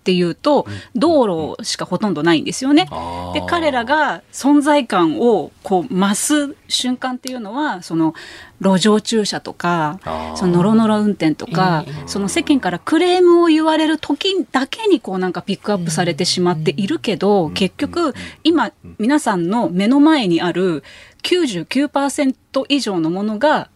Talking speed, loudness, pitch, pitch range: 305 characters per minute, -17 LUFS, 215 Hz, 180-295 Hz